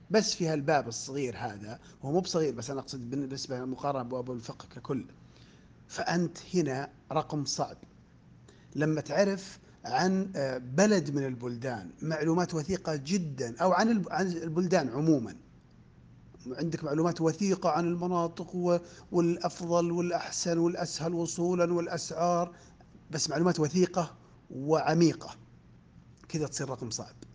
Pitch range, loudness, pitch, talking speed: 130-175 Hz, -31 LUFS, 160 Hz, 110 wpm